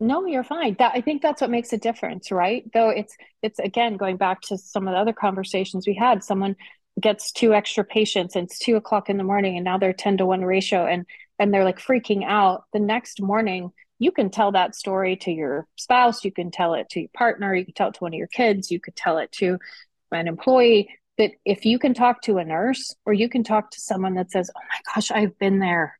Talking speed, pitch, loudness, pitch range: 245 wpm, 205 Hz, -22 LUFS, 190-230 Hz